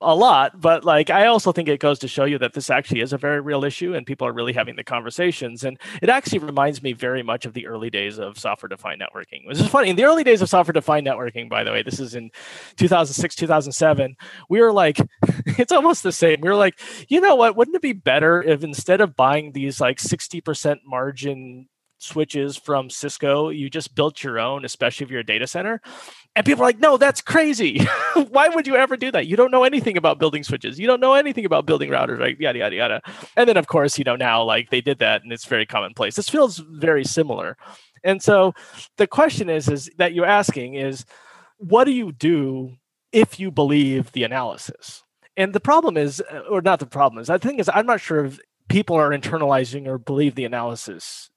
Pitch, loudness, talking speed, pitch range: 155 Hz, -19 LUFS, 225 wpm, 135-205 Hz